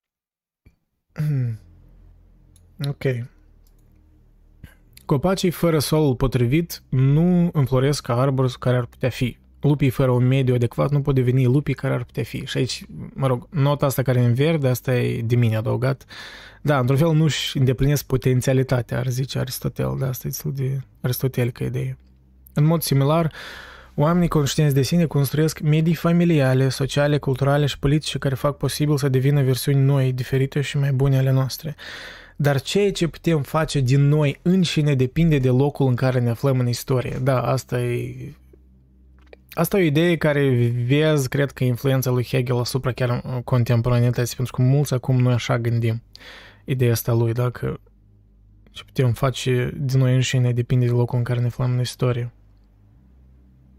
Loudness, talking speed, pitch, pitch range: -21 LUFS, 160 wpm, 130 Hz, 120-145 Hz